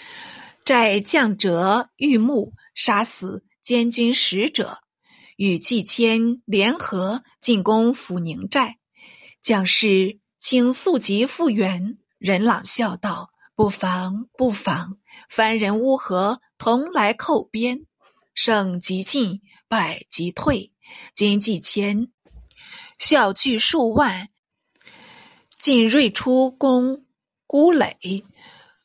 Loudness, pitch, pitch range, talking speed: -19 LUFS, 225 Hz, 200-255 Hz, 135 characters per minute